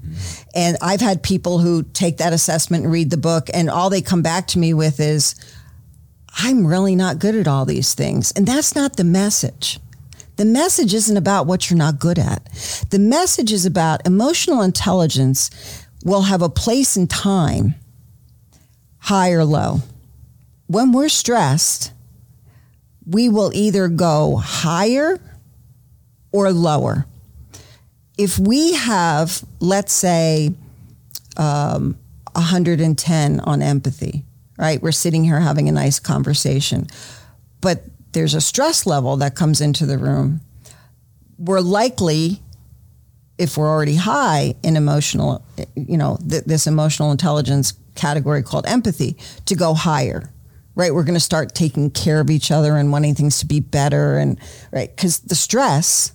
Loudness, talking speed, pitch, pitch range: -17 LUFS, 145 wpm, 155 Hz, 135-185 Hz